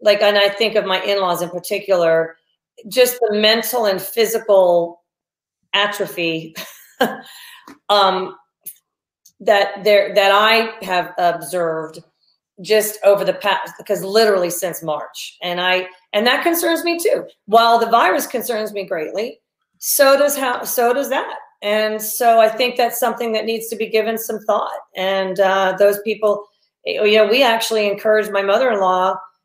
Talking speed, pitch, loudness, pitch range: 150 wpm, 205 Hz, -17 LUFS, 190-225 Hz